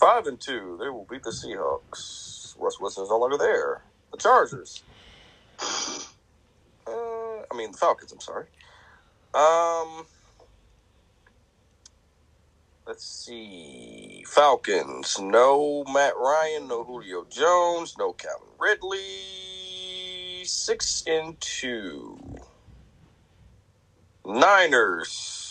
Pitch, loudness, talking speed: 160 Hz, -25 LUFS, 95 wpm